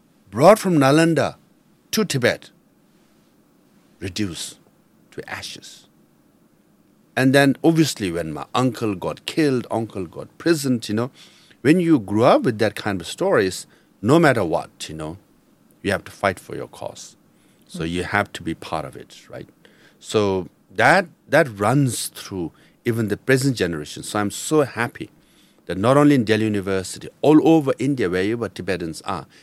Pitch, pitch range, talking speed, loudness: 120 Hz, 100-145 Hz, 160 wpm, -20 LUFS